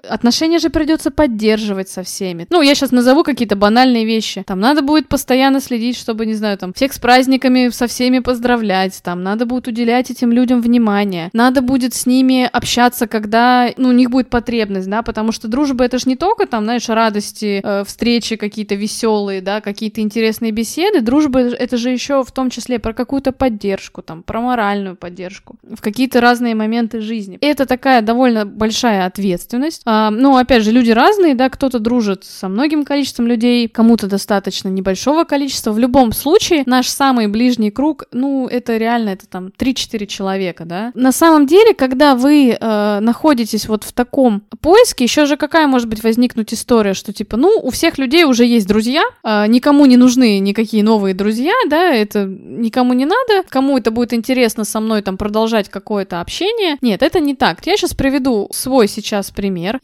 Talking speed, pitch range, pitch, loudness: 180 wpm, 215-265 Hz, 240 Hz, -14 LUFS